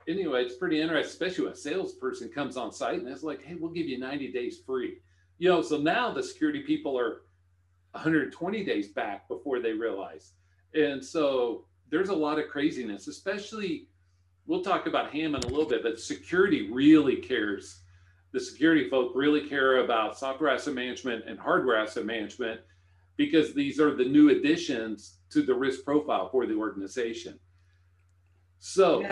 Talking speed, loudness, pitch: 165 wpm, -28 LUFS, 145 Hz